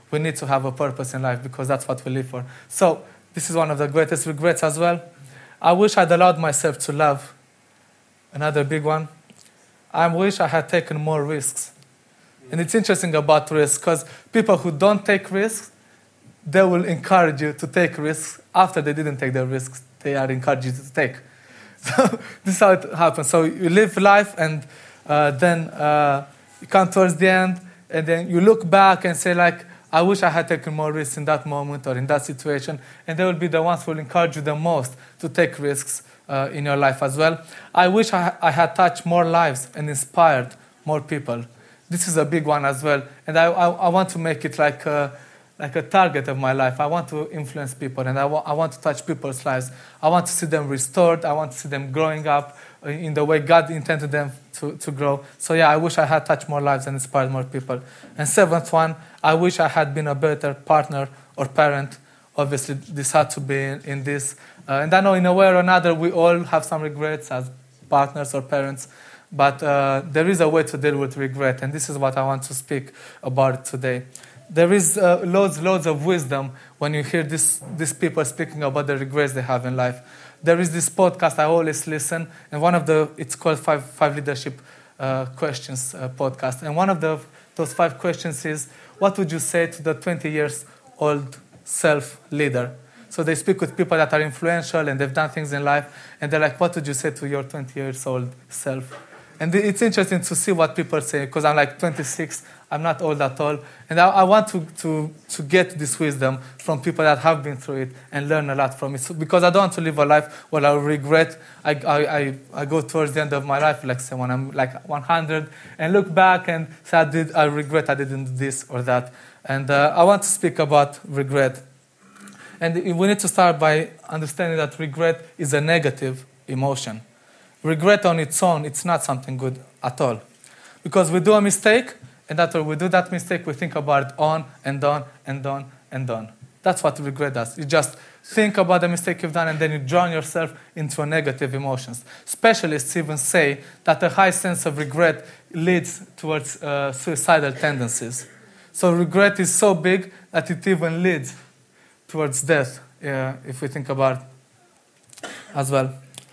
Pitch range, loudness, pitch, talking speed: 140-170 Hz, -20 LUFS, 155 Hz, 210 wpm